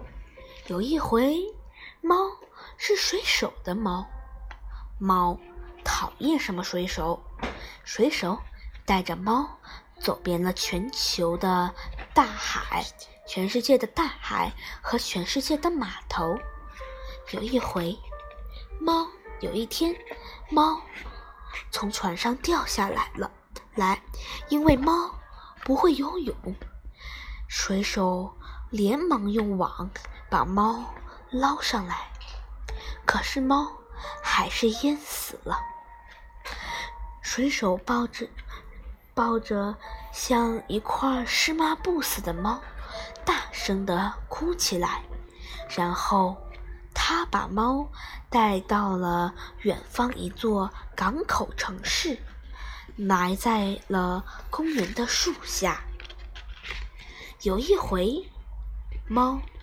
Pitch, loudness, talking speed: 230 Hz, -27 LUFS, 135 characters per minute